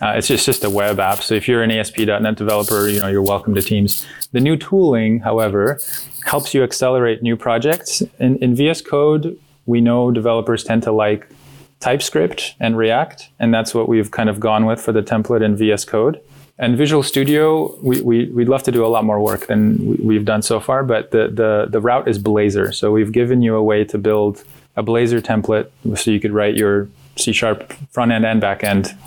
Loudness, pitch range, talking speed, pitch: -16 LUFS, 105-125 Hz, 215 wpm, 115 Hz